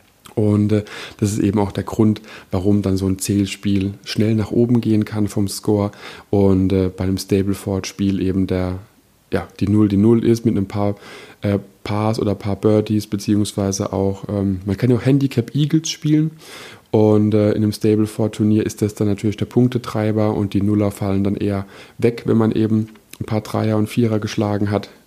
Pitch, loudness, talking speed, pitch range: 105 Hz, -19 LUFS, 190 wpm, 100-110 Hz